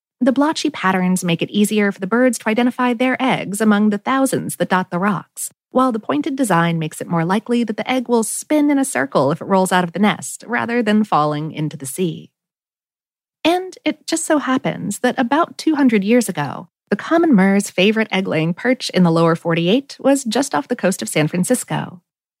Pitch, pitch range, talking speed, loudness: 215 Hz, 180-255 Hz, 210 wpm, -18 LUFS